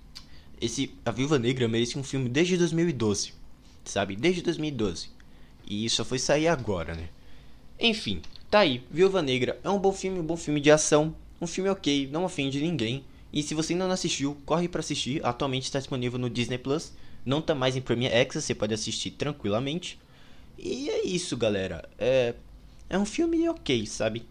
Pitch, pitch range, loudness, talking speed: 140 Hz, 120-170 Hz, -27 LUFS, 185 wpm